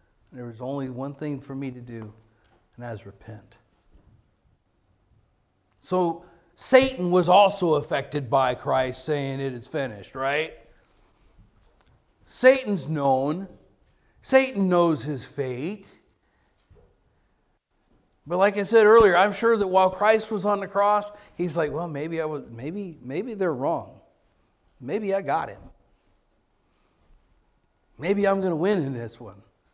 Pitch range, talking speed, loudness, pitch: 125-195 Hz, 135 wpm, -23 LUFS, 155 Hz